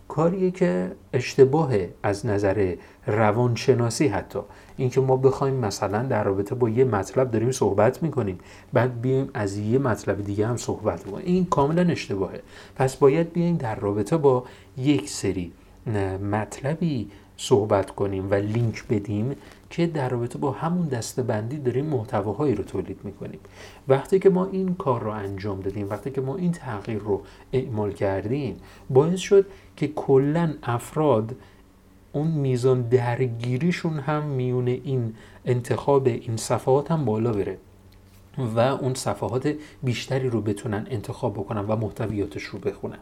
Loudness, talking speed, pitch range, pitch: -24 LUFS, 140 wpm, 105-135 Hz, 125 Hz